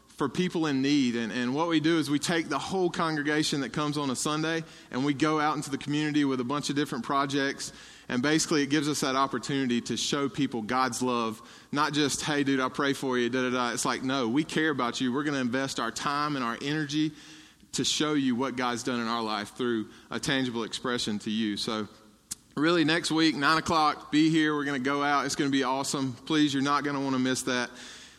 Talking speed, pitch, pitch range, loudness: 245 wpm, 140 Hz, 125-150 Hz, -28 LUFS